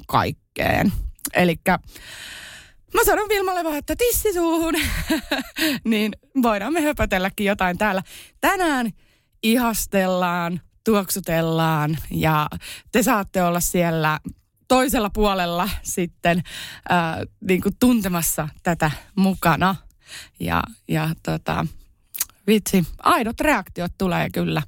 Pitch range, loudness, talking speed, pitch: 170-255 Hz, -21 LUFS, 95 wpm, 195 Hz